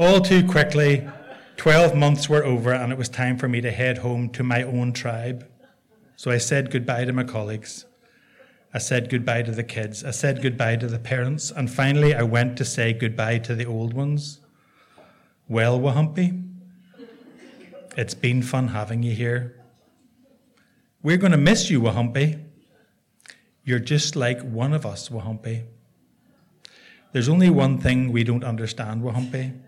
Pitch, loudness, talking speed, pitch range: 130 Hz, -22 LUFS, 160 wpm, 120-150 Hz